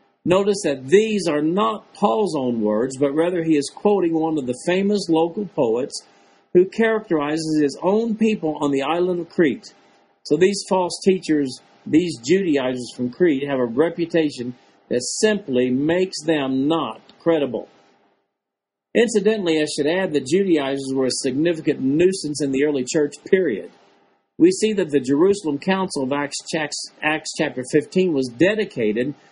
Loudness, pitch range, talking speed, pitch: -20 LUFS, 130-185 Hz, 150 wpm, 155 Hz